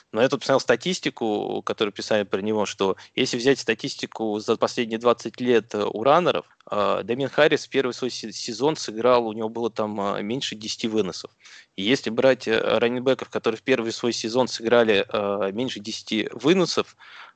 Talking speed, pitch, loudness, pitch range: 155 wpm, 115 Hz, -23 LUFS, 110-125 Hz